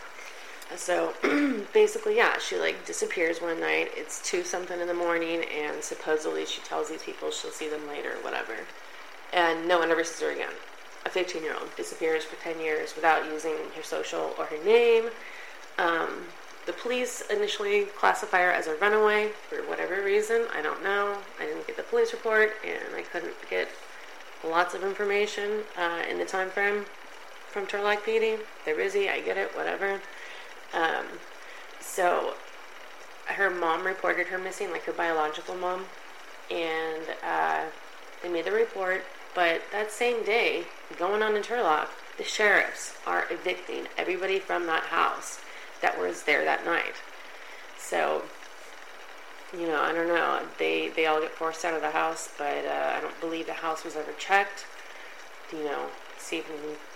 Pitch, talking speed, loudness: 205 Hz, 165 wpm, -28 LUFS